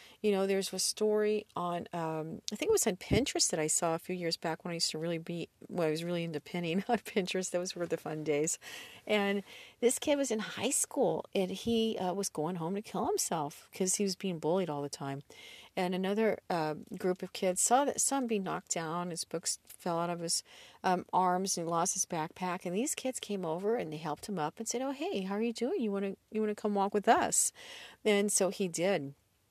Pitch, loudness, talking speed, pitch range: 185 Hz, -33 LUFS, 240 wpm, 170-215 Hz